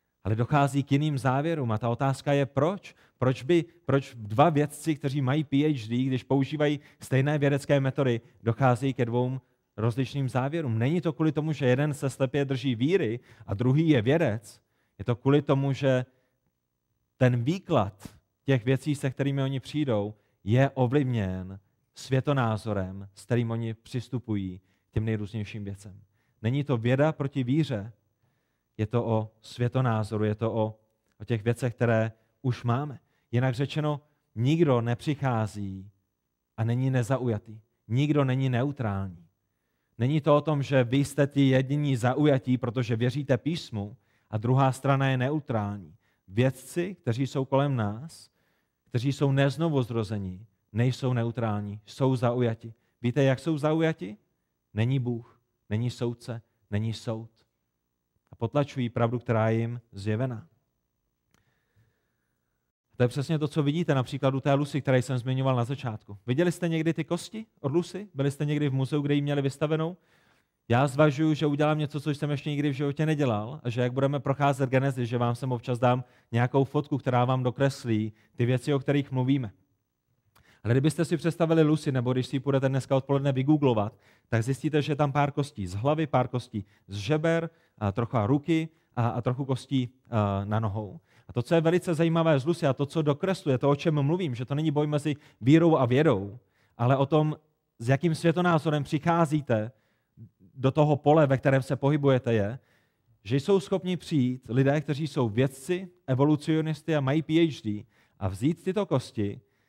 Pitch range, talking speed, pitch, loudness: 115-145 Hz, 160 wpm, 130 Hz, -27 LUFS